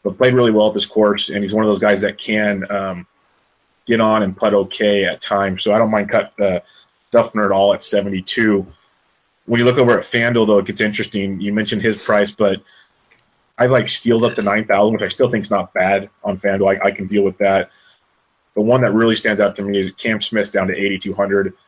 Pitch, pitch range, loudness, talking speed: 100 Hz, 100-110 Hz, -16 LUFS, 235 wpm